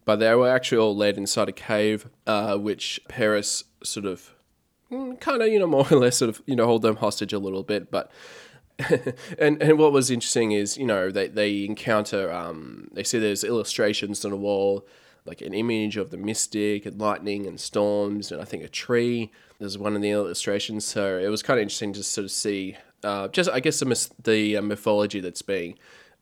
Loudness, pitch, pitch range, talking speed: -24 LUFS, 105 Hz, 100-115 Hz, 210 wpm